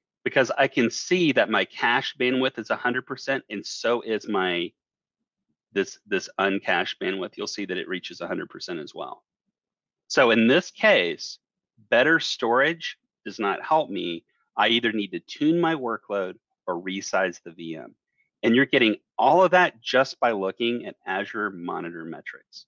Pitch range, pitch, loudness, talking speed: 100-135 Hz, 120 Hz, -24 LUFS, 160 wpm